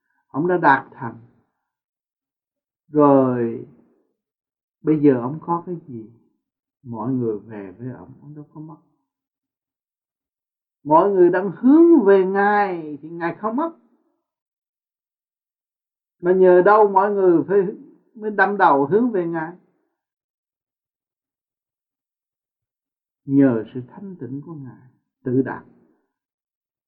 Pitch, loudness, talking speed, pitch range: 170 Hz, -18 LUFS, 115 wpm, 135-200 Hz